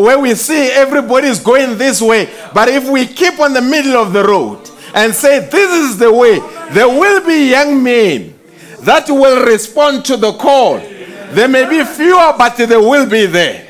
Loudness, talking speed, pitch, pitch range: -9 LUFS, 195 wpm, 265 Hz, 235-290 Hz